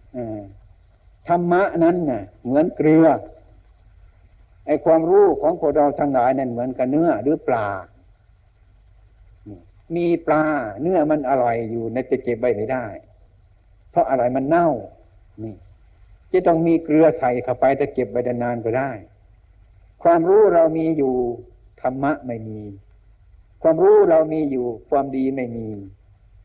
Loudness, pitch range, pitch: -19 LUFS, 100-150 Hz, 120 Hz